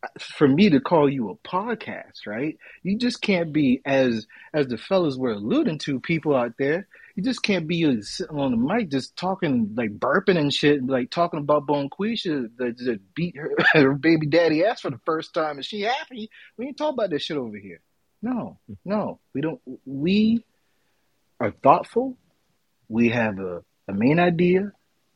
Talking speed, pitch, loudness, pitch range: 185 wpm, 165 Hz, -23 LUFS, 140-205 Hz